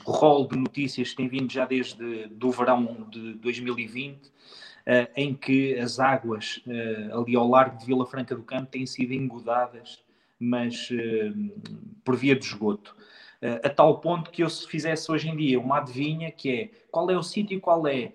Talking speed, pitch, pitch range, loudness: 190 wpm, 130 Hz, 120-150 Hz, -26 LUFS